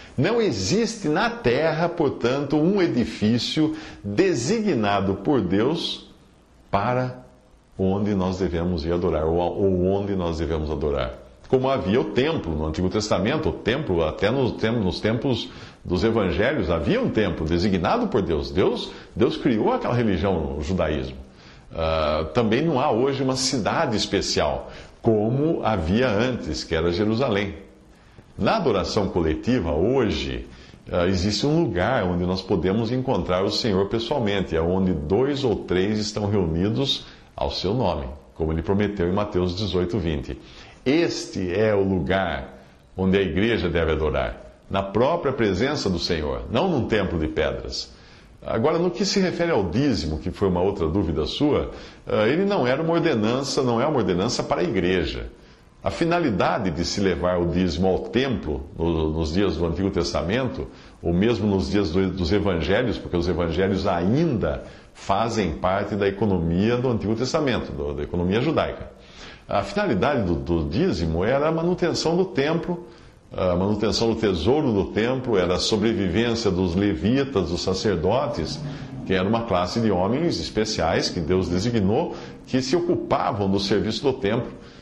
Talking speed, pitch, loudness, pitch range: 150 wpm, 95 Hz, -23 LUFS, 85-115 Hz